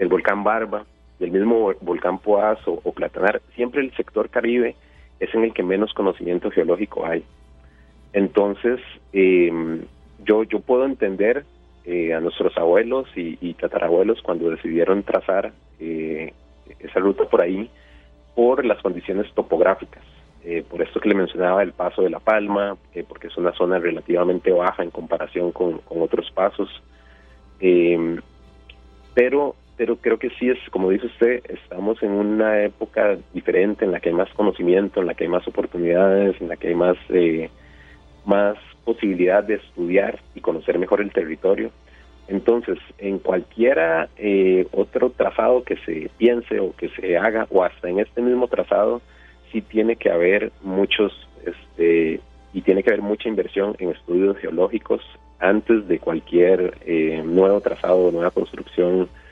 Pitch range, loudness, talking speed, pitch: 75-105 Hz, -21 LUFS, 155 wpm, 90 Hz